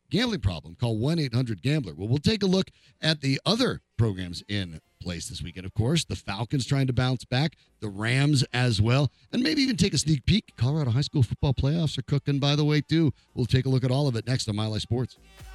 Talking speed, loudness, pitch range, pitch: 240 wpm, -26 LUFS, 115-155 Hz, 130 Hz